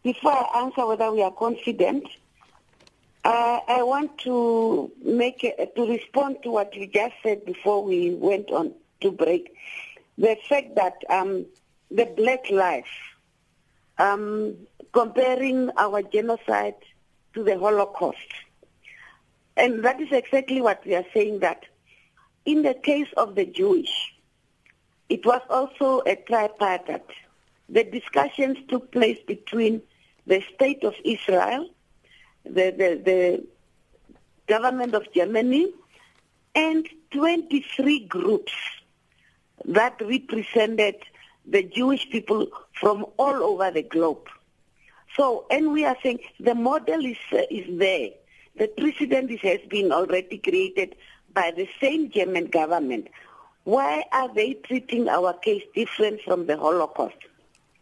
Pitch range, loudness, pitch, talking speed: 200-280 Hz, -24 LUFS, 235 Hz, 125 wpm